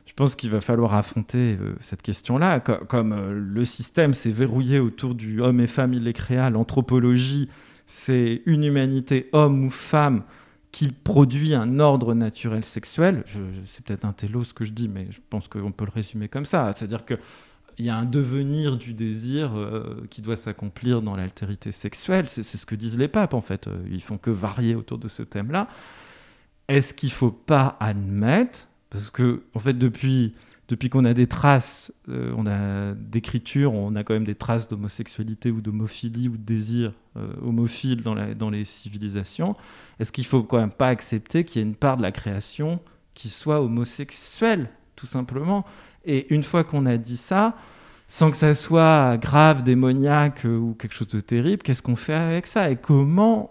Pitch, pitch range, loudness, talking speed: 120 Hz, 110-140 Hz, -23 LUFS, 195 wpm